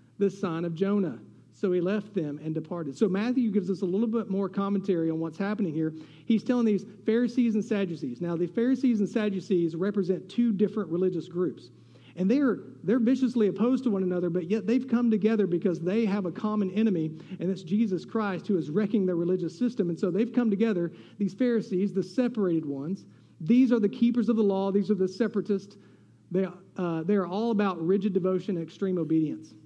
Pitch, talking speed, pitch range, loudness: 195 Hz, 200 wpm, 175-220 Hz, -28 LUFS